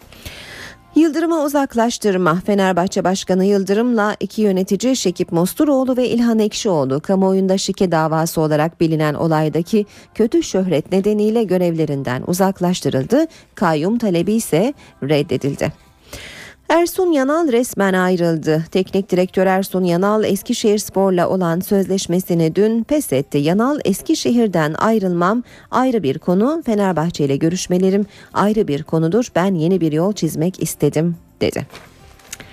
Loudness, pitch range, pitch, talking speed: -17 LUFS, 165-220 Hz, 190 Hz, 110 wpm